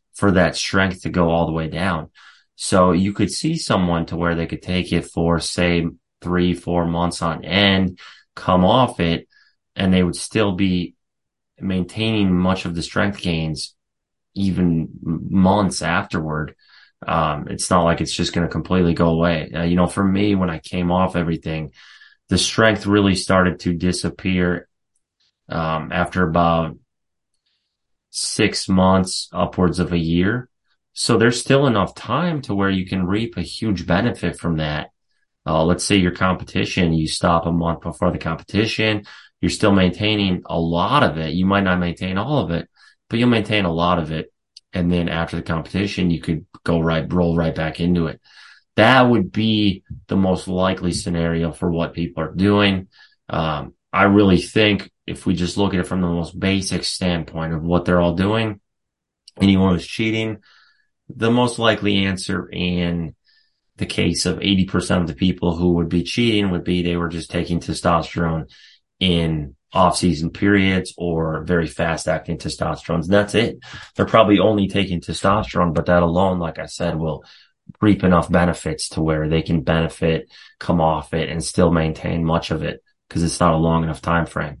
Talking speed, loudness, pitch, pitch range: 175 wpm, -19 LUFS, 90 Hz, 85-100 Hz